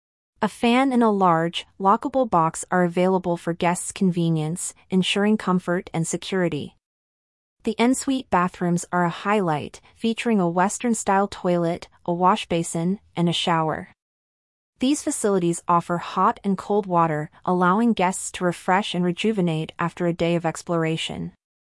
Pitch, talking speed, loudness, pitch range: 180 Hz, 145 wpm, -22 LUFS, 170-205 Hz